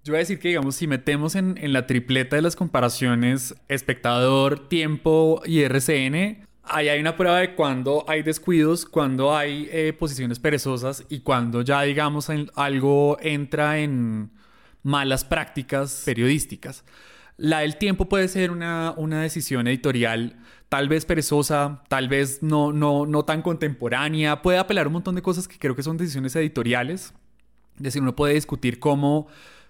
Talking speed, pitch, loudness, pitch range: 160 wpm, 150 Hz, -23 LUFS, 135-160 Hz